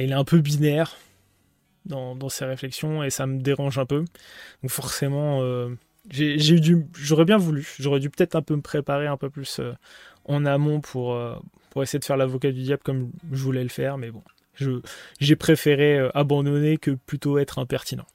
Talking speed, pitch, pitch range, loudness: 200 wpm, 140 Hz, 130-150 Hz, -23 LUFS